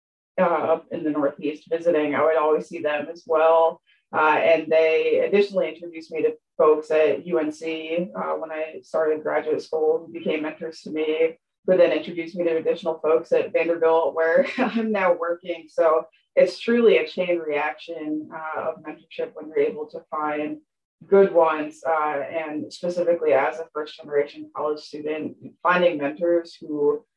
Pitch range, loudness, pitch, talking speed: 155-175 Hz, -23 LUFS, 160 Hz, 165 wpm